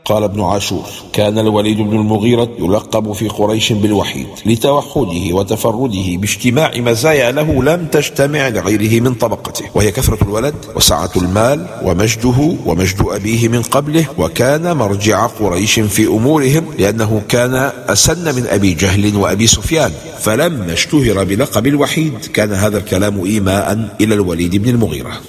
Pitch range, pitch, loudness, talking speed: 100-130 Hz, 110 Hz, -13 LUFS, 135 wpm